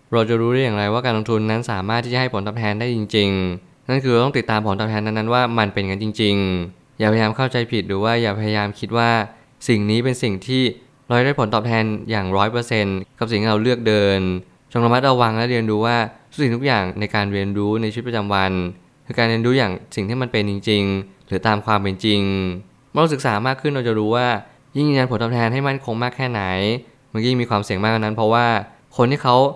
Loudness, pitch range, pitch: -19 LUFS, 105-125 Hz, 115 Hz